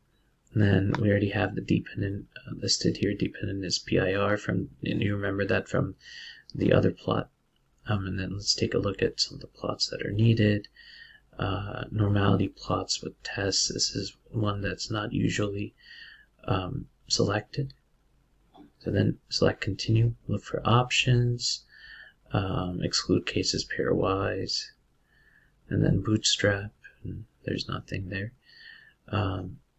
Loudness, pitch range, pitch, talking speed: -28 LUFS, 100-115 Hz, 105 Hz, 140 wpm